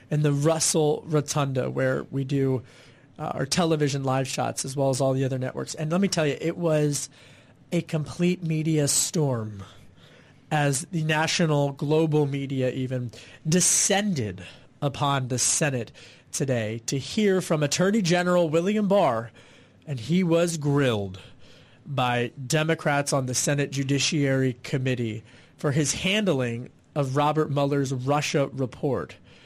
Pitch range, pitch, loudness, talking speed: 130-160 Hz, 145 Hz, -25 LUFS, 135 wpm